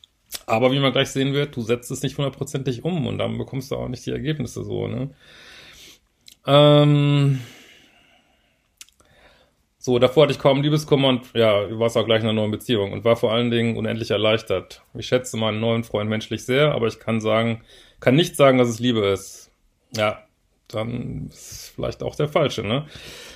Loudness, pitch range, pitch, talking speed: -21 LUFS, 115-135 Hz, 125 Hz, 190 wpm